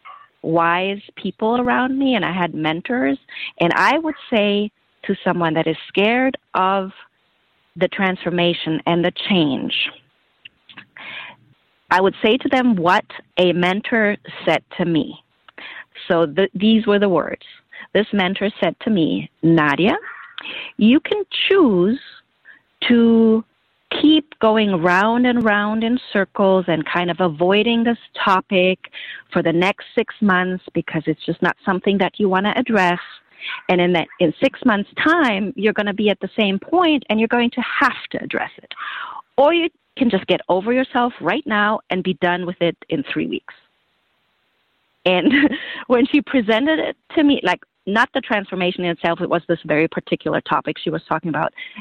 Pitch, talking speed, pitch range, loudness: 205 Hz, 165 wpm, 180-245 Hz, -18 LUFS